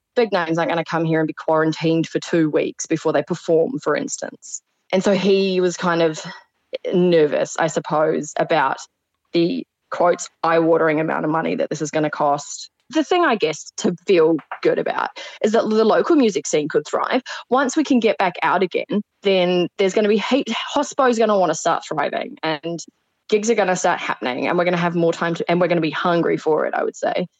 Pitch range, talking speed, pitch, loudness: 160-215 Hz, 225 wpm, 175 Hz, -19 LUFS